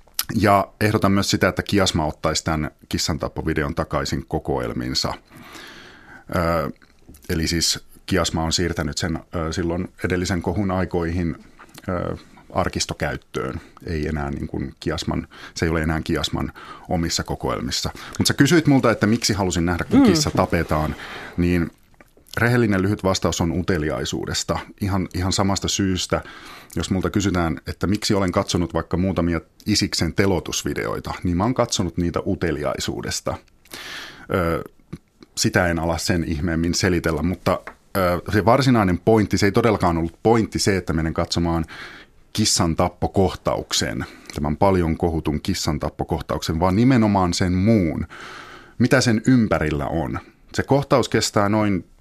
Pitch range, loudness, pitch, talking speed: 80-100 Hz, -21 LUFS, 90 Hz, 135 wpm